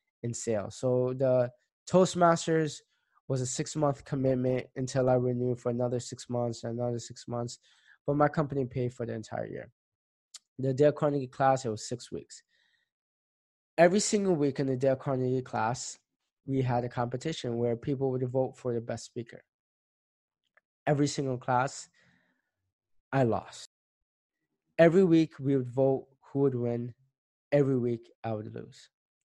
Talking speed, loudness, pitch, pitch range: 150 wpm, -30 LUFS, 130 Hz, 120-140 Hz